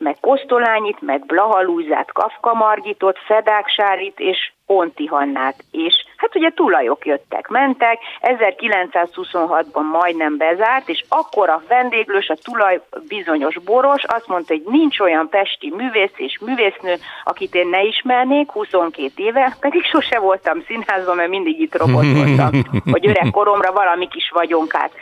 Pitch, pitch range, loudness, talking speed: 200 Hz, 165-250 Hz, -16 LUFS, 135 wpm